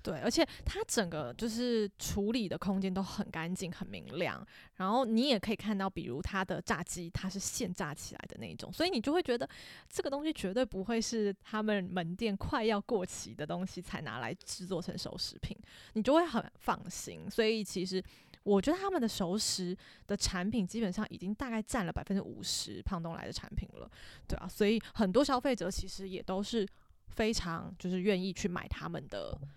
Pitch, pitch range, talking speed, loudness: 200 Hz, 185-230 Hz, 300 characters per minute, -35 LUFS